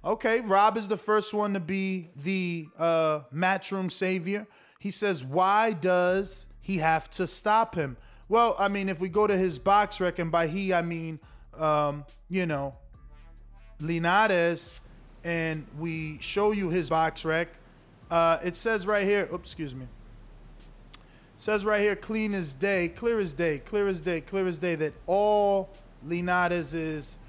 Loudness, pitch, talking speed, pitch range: -27 LUFS, 175 Hz, 165 wpm, 160-200 Hz